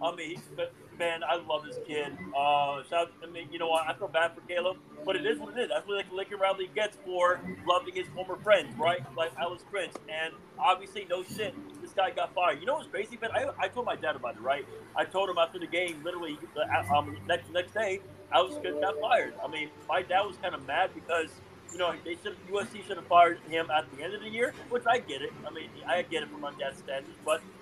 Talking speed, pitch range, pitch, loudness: 255 wpm, 165-195 Hz, 180 Hz, -31 LUFS